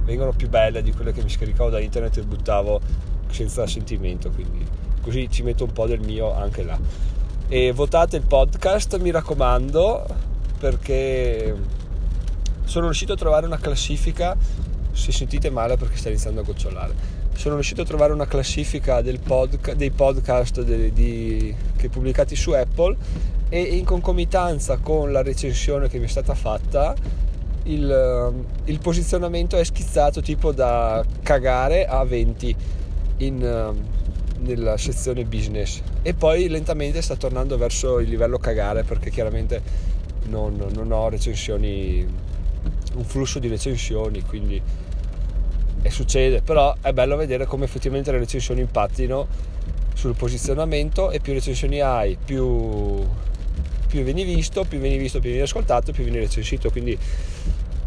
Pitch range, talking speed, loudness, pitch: 90-135 Hz, 140 wpm, -23 LUFS, 115 Hz